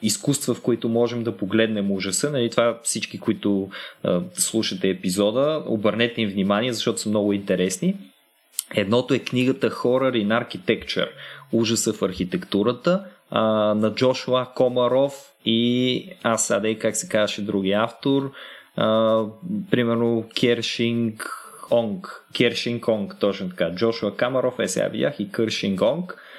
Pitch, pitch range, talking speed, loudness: 115 Hz, 105-125 Hz, 130 wpm, -23 LUFS